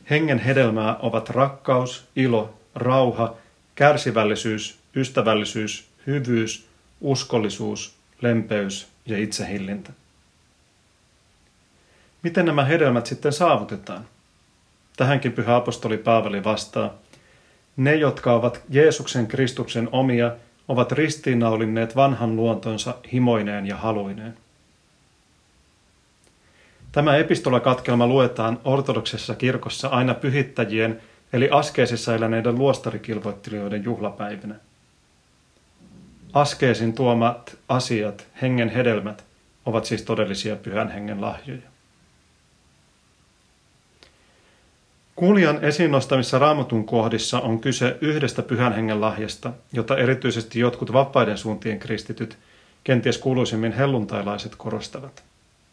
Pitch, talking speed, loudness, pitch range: 120 Hz, 85 wpm, -22 LUFS, 110-130 Hz